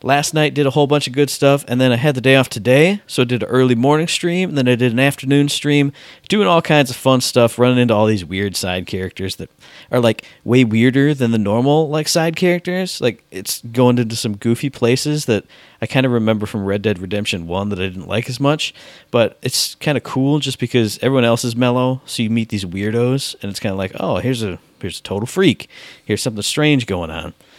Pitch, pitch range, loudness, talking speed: 125 Hz, 110-145 Hz, -17 LUFS, 240 wpm